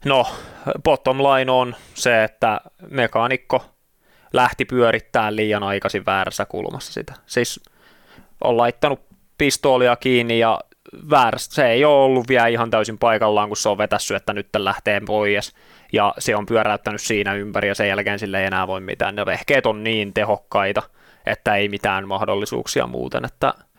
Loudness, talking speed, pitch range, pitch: -19 LUFS, 155 wpm, 100-120 Hz, 105 Hz